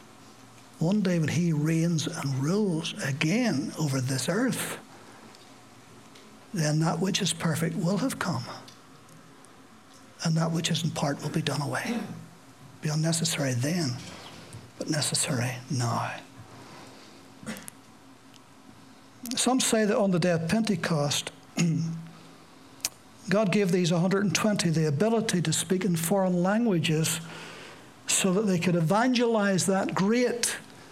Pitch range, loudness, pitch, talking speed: 155-195 Hz, -27 LUFS, 170 Hz, 120 wpm